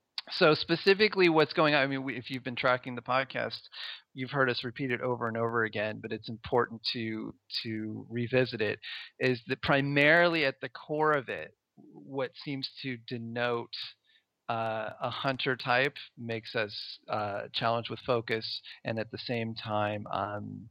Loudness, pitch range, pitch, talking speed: -30 LUFS, 115-135 Hz, 125 Hz, 170 wpm